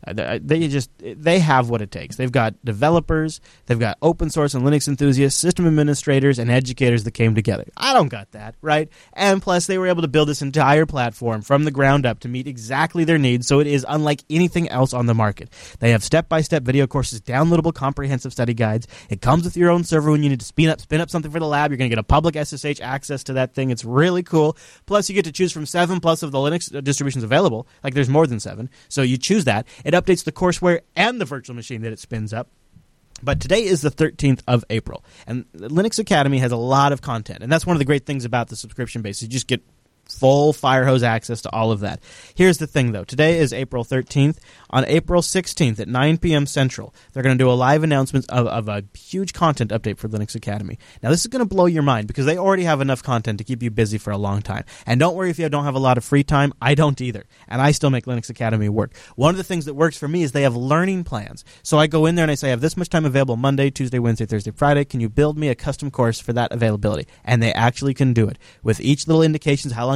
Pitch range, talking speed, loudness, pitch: 120-155 Hz, 255 wpm, -19 LUFS, 140 Hz